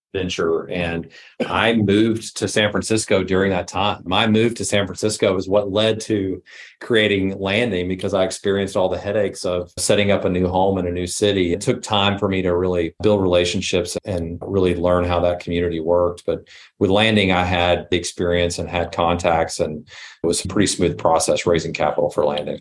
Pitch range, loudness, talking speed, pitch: 90-105 Hz, -19 LUFS, 195 wpm, 95 Hz